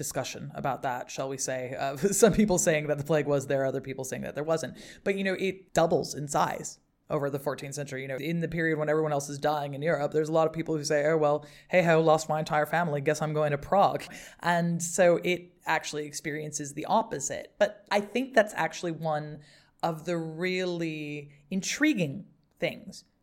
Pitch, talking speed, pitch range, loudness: 155 Hz, 210 wpm, 145-175 Hz, -28 LUFS